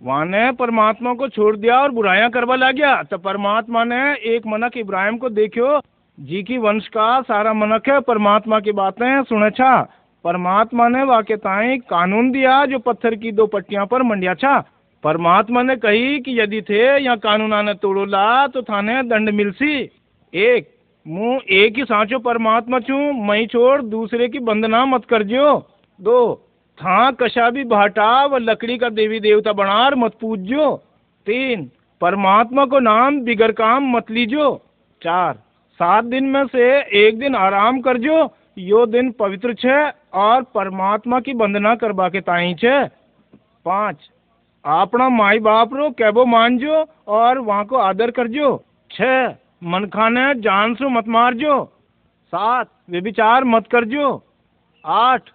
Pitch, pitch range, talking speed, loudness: 235 Hz, 210-260 Hz, 155 wpm, -16 LUFS